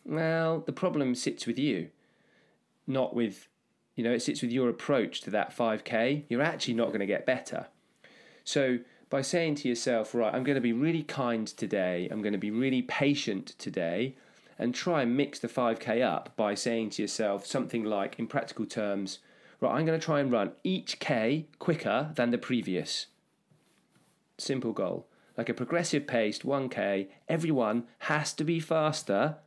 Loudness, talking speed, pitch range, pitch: -31 LUFS, 175 wpm, 115-150 Hz, 125 Hz